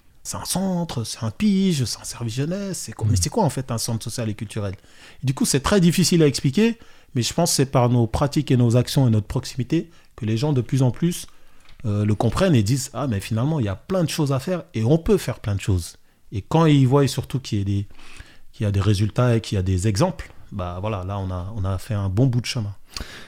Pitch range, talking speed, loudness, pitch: 105-145 Hz, 275 wpm, -22 LUFS, 120 Hz